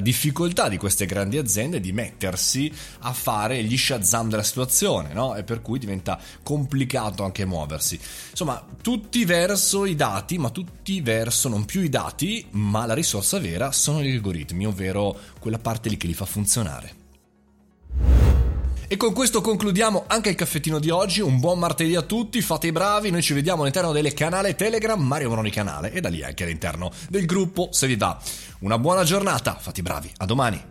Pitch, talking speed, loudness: 125 Hz, 180 wpm, -23 LUFS